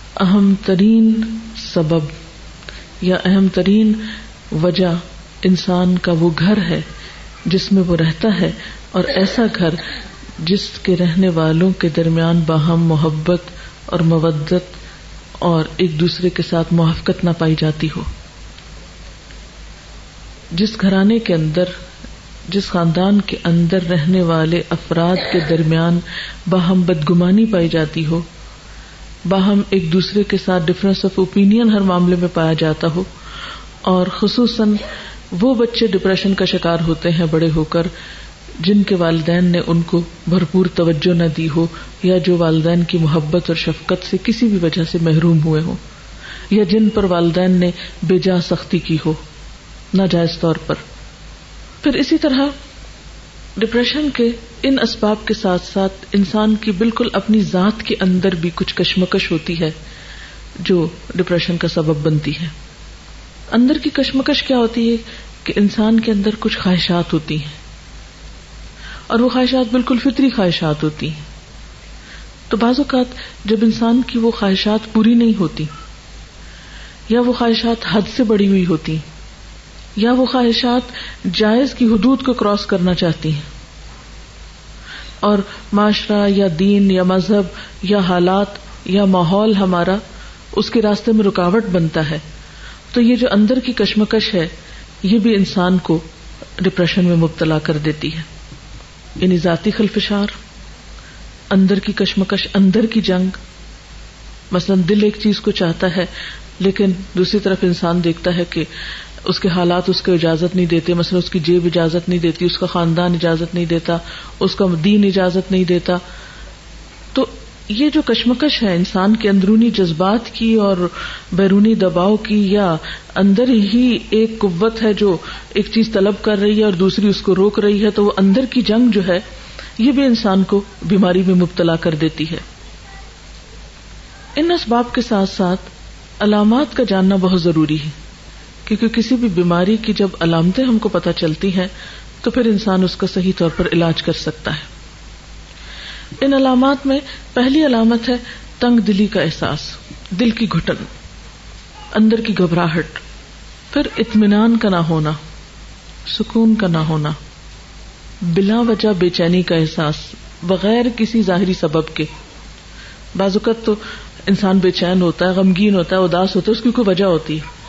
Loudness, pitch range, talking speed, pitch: -15 LUFS, 170-215 Hz, 155 wpm, 185 Hz